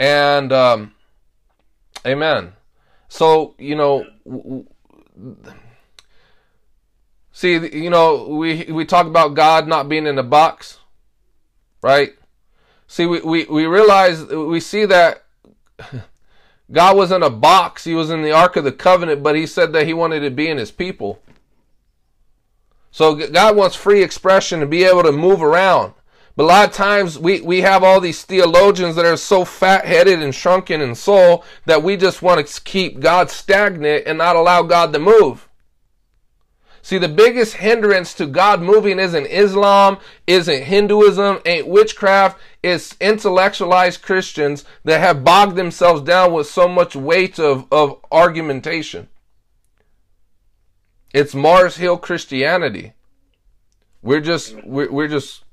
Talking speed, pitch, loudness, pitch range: 145 wpm, 170 Hz, -14 LUFS, 145-190 Hz